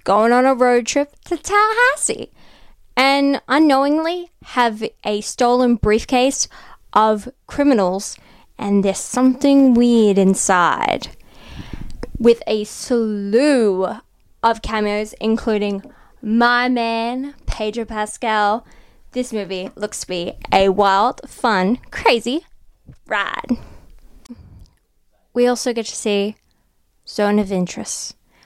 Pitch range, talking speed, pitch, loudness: 210-255 Hz, 100 wpm, 230 Hz, -18 LUFS